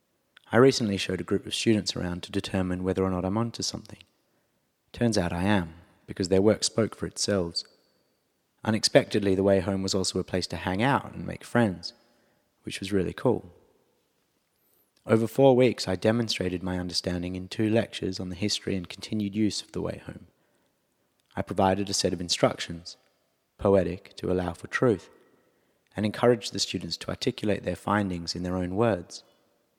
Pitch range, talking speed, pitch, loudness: 90-110 Hz, 175 wpm, 100 Hz, -27 LUFS